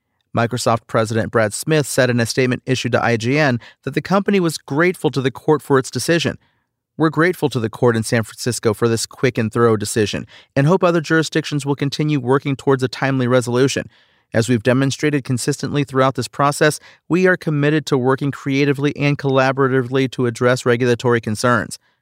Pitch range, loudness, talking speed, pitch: 120-145 Hz, -18 LUFS, 180 wpm, 130 Hz